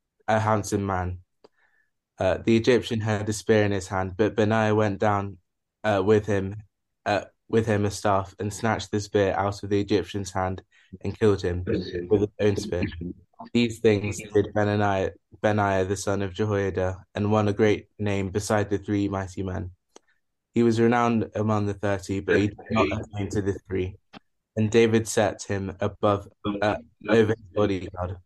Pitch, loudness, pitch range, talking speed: 105 Hz, -25 LUFS, 95-110 Hz, 175 wpm